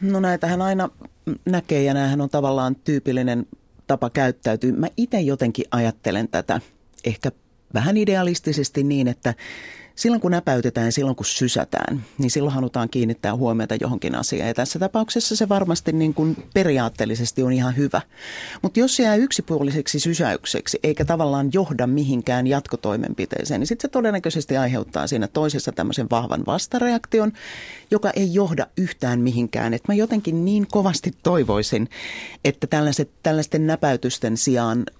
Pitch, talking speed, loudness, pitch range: 145 Hz, 140 wpm, -22 LUFS, 125-185 Hz